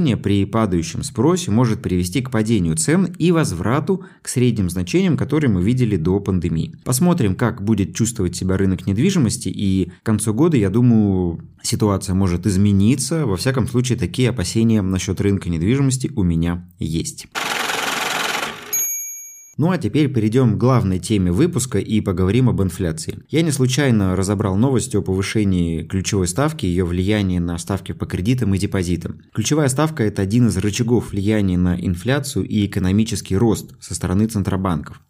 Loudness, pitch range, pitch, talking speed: -19 LUFS, 95-125 Hz, 105 Hz, 155 wpm